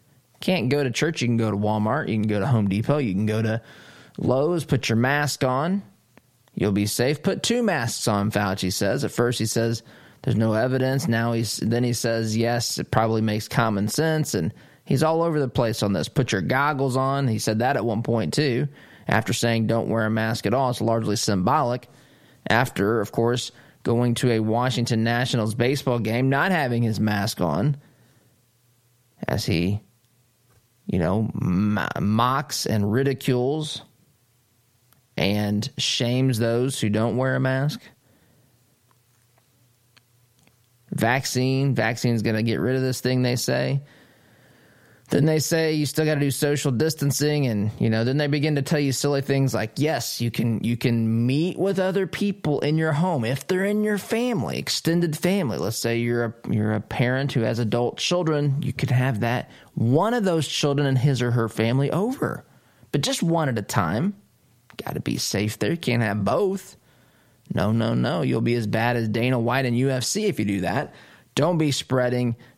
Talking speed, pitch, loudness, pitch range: 185 wpm, 120 Hz, -23 LUFS, 115-140 Hz